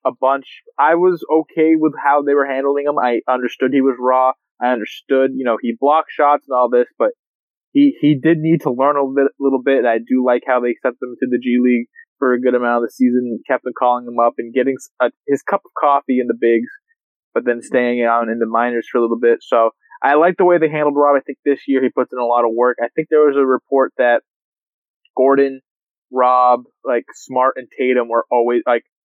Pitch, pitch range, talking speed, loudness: 130 Hz, 125-145 Hz, 250 wpm, -16 LUFS